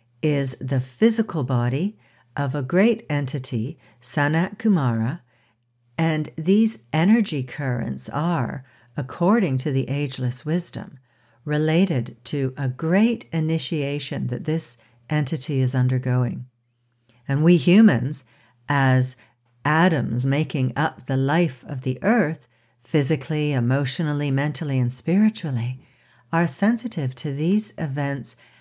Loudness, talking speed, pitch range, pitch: -22 LUFS, 110 wpm, 125-160 Hz, 140 Hz